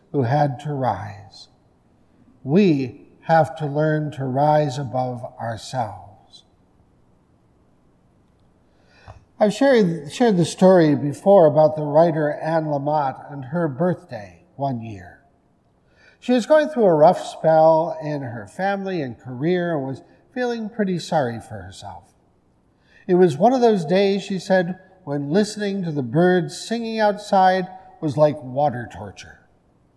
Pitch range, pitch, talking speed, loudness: 130-185 Hz, 155 Hz, 130 wpm, -20 LUFS